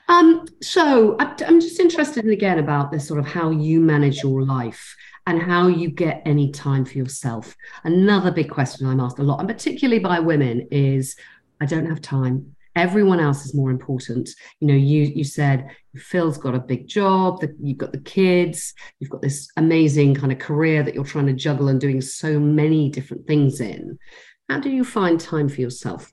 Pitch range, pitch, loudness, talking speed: 135-175 Hz, 150 Hz, -20 LUFS, 195 wpm